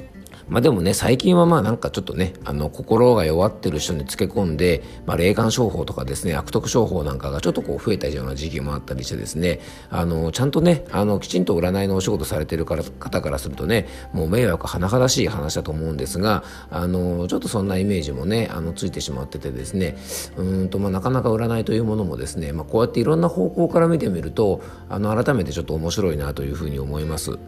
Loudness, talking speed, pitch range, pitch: -22 LUFS, 480 characters per minute, 75-110 Hz, 90 Hz